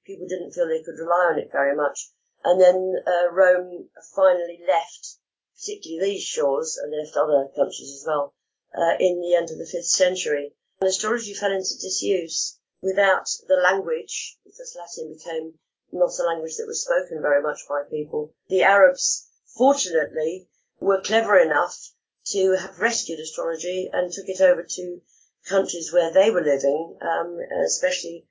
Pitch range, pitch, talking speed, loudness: 165-215 Hz, 185 Hz, 160 wpm, -22 LUFS